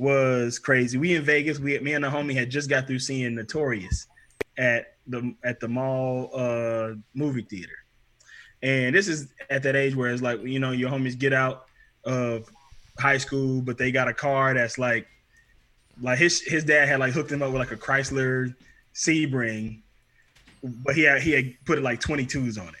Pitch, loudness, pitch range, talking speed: 130 Hz, -24 LUFS, 120-140 Hz, 195 wpm